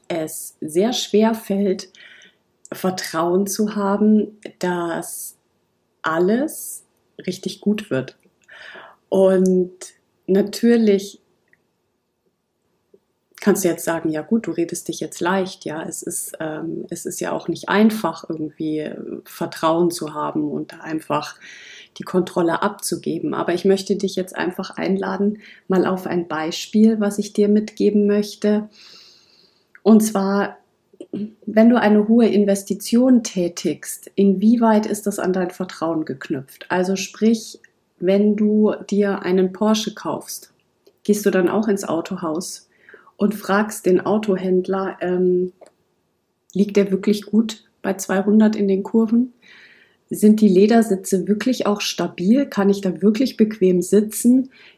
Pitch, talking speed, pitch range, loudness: 195 Hz, 125 wpm, 180-210 Hz, -20 LUFS